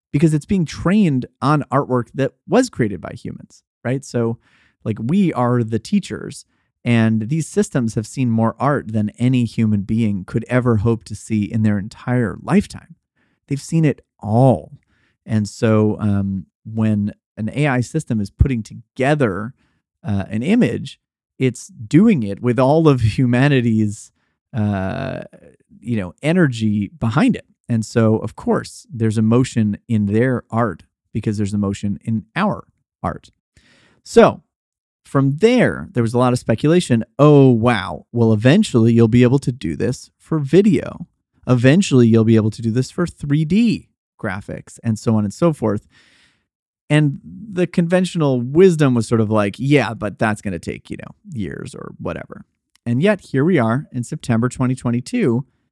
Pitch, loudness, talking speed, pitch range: 120 Hz, -18 LUFS, 160 wpm, 110-140 Hz